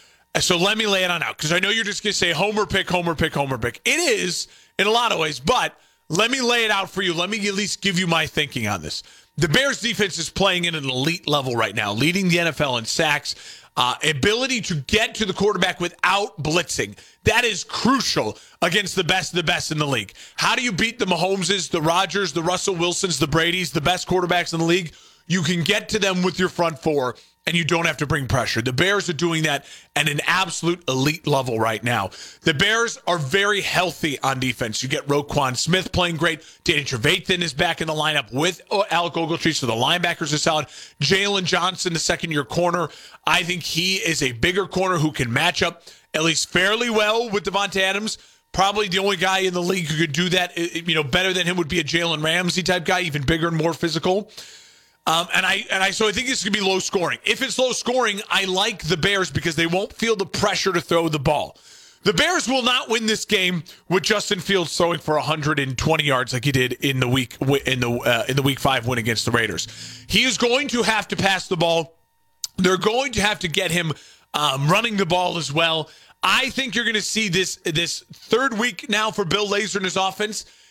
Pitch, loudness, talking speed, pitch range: 175 Hz, -20 LUFS, 230 wpm, 155-195 Hz